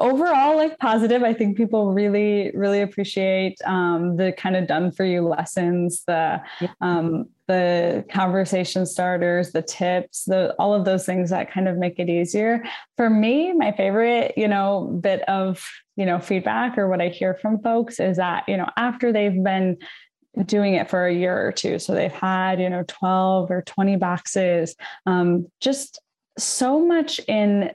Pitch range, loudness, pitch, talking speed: 180-210 Hz, -21 LUFS, 190 Hz, 170 wpm